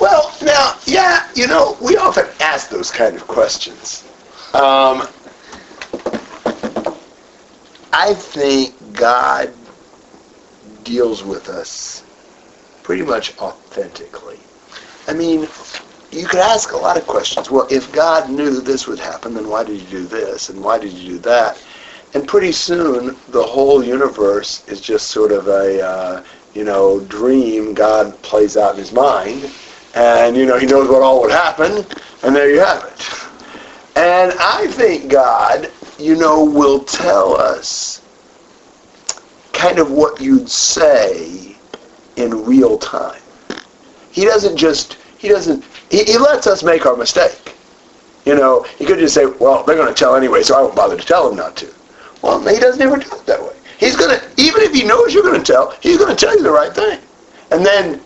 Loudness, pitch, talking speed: -13 LUFS, 155 Hz, 170 wpm